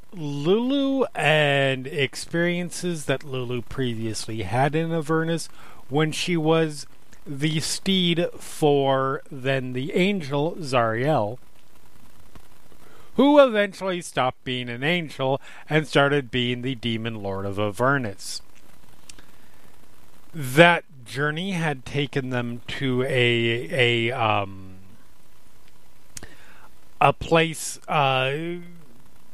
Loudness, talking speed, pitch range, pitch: -23 LUFS, 90 wpm, 125-165 Hz, 140 Hz